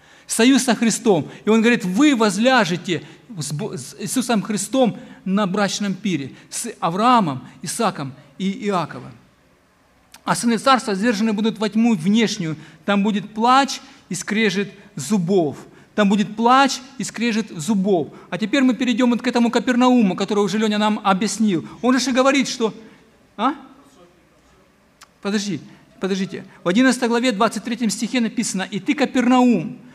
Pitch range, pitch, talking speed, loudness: 195-240 Hz, 220 Hz, 135 wpm, -19 LUFS